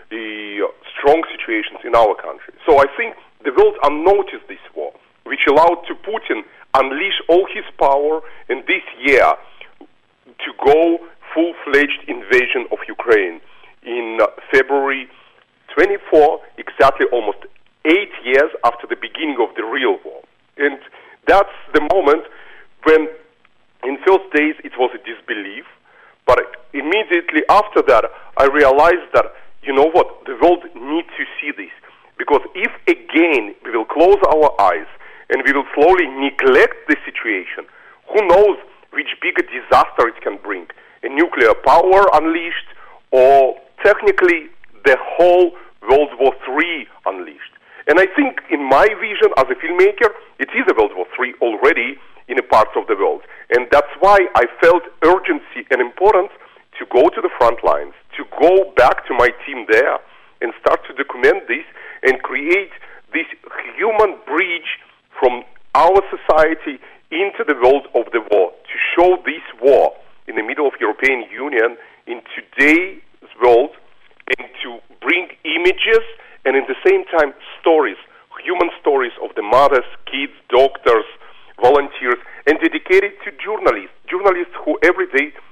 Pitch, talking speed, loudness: 380 Hz, 150 wpm, -15 LUFS